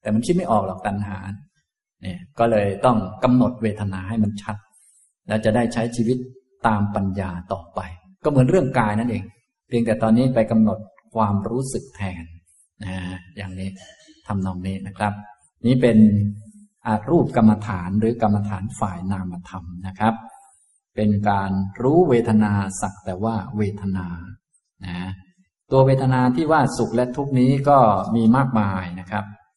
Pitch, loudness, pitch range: 110 Hz, -21 LUFS, 95-120 Hz